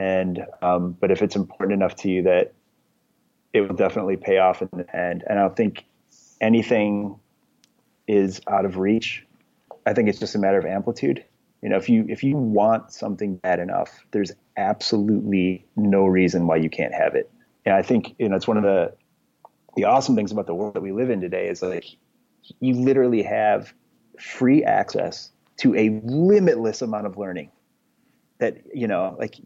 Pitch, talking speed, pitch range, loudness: 100 Hz, 185 wpm, 95-115 Hz, -22 LUFS